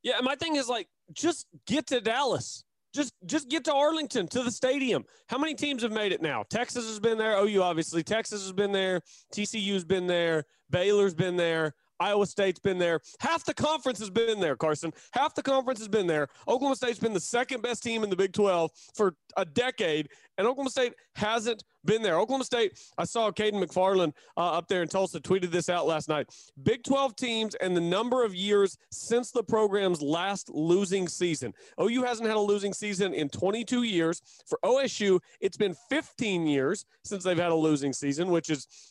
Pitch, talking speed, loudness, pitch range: 205 Hz, 200 wpm, -29 LUFS, 175-245 Hz